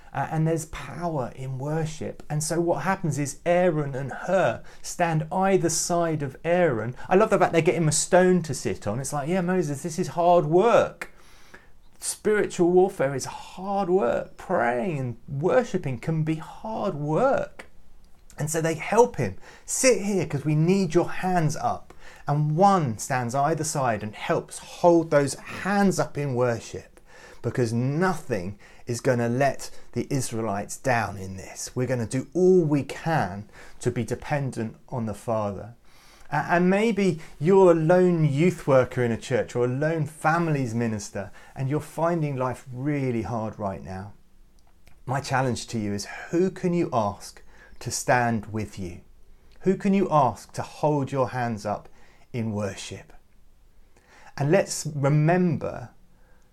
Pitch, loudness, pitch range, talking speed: 150 Hz, -25 LUFS, 120-175 Hz, 160 wpm